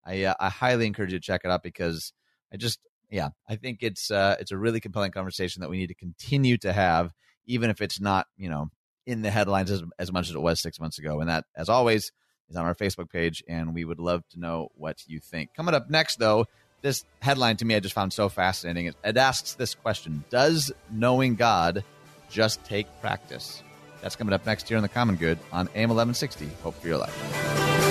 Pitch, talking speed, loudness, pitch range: 95 Hz, 225 wpm, -27 LUFS, 85-115 Hz